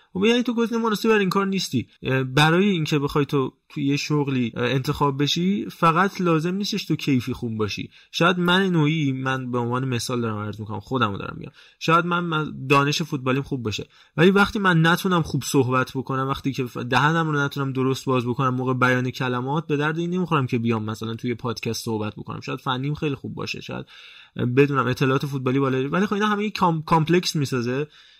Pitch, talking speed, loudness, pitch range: 140 Hz, 185 wpm, -22 LUFS, 130-170 Hz